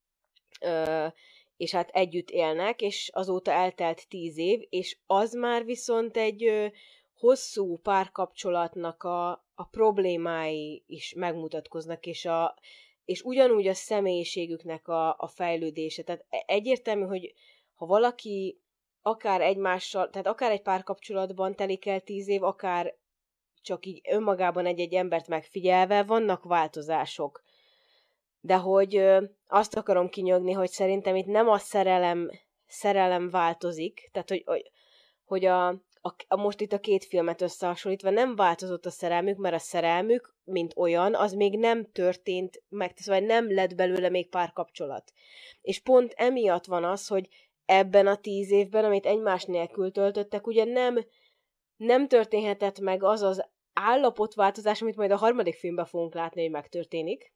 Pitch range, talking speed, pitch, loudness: 175-210 Hz, 140 wpm, 190 Hz, -27 LUFS